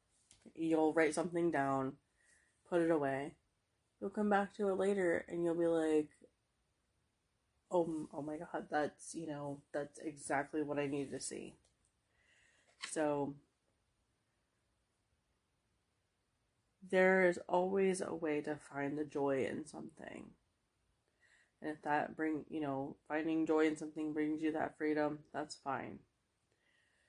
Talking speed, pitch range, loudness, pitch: 130 wpm, 140-165 Hz, -38 LUFS, 150 Hz